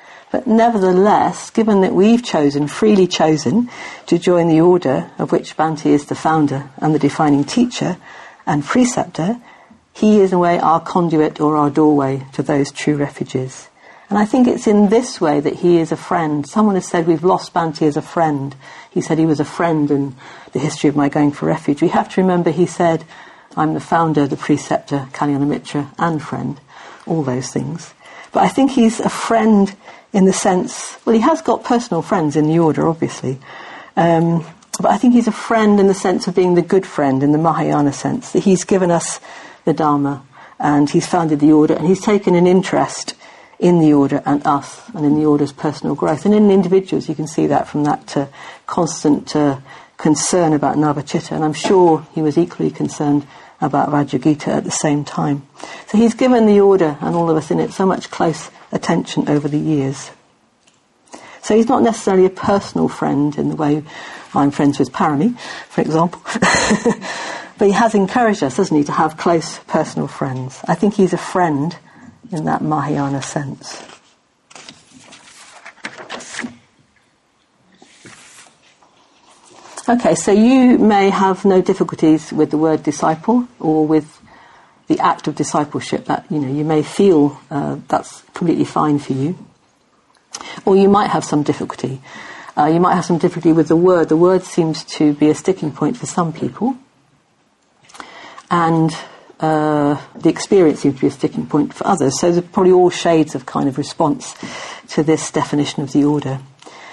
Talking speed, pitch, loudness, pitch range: 180 wpm, 165 Hz, -16 LUFS, 150-190 Hz